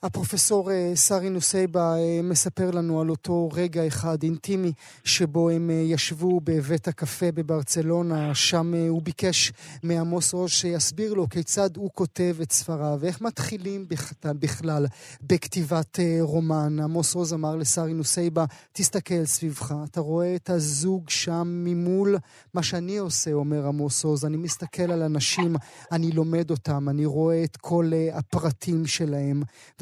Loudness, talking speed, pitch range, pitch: -25 LUFS, 130 wpm, 155-175 Hz, 165 Hz